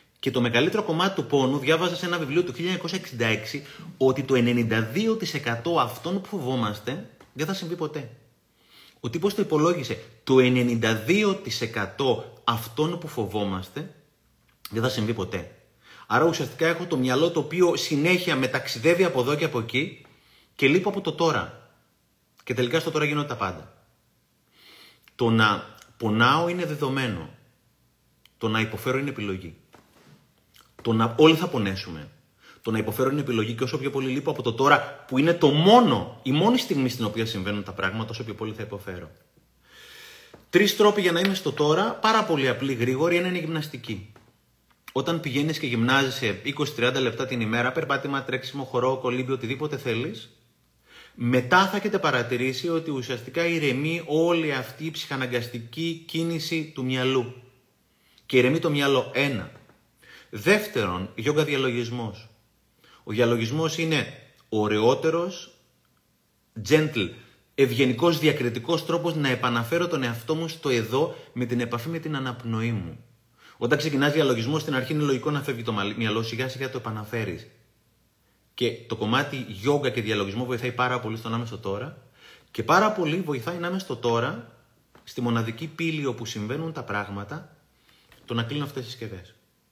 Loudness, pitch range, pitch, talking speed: -25 LUFS, 115-160 Hz, 130 Hz, 150 wpm